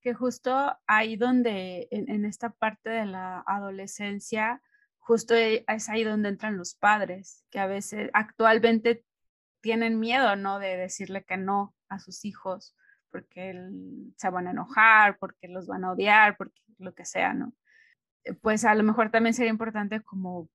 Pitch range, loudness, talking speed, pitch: 195-230 Hz, -26 LUFS, 160 wpm, 215 Hz